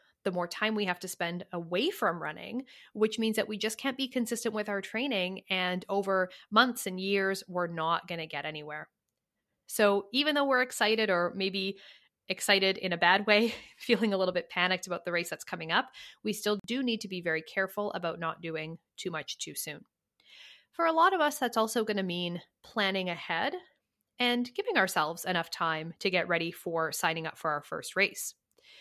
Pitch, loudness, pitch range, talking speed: 195 Hz, -30 LUFS, 175-225 Hz, 200 wpm